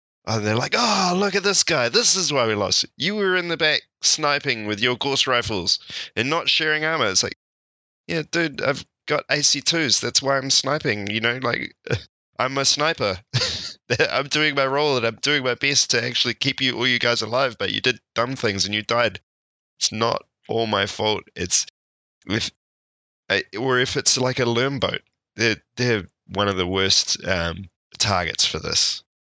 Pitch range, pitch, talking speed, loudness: 105-145 Hz, 125 Hz, 195 wpm, -21 LUFS